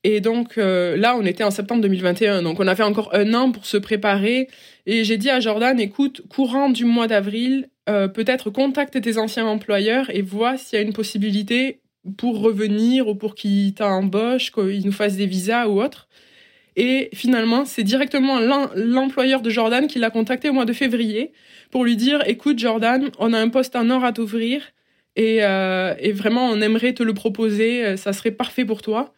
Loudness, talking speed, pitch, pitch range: -20 LUFS, 195 wpm, 225 Hz, 210-255 Hz